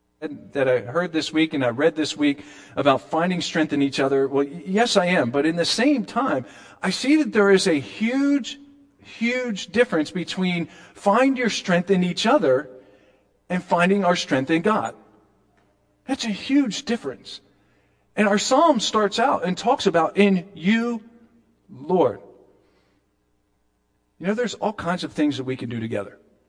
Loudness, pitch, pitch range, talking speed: -22 LUFS, 175 Hz, 135-220 Hz, 170 wpm